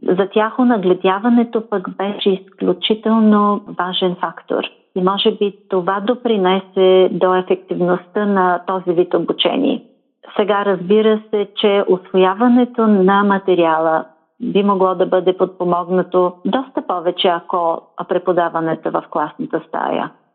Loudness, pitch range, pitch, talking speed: -16 LUFS, 180-215 Hz, 190 Hz, 110 wpm